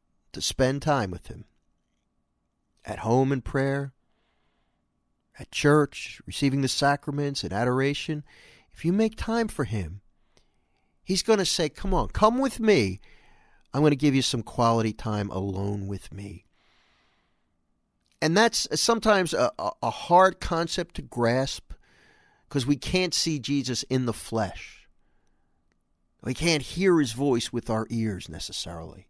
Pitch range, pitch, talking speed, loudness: 100-155 Hz, 130 Hz, 140 wpm, -25 LUFS